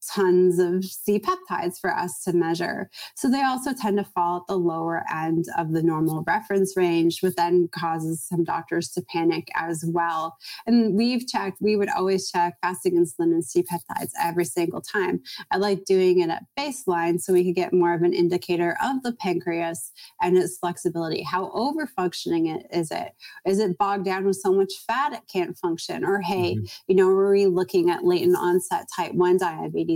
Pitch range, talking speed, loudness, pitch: 170-195 Hz, 195 wpm, -24 LUFS, 180 Hz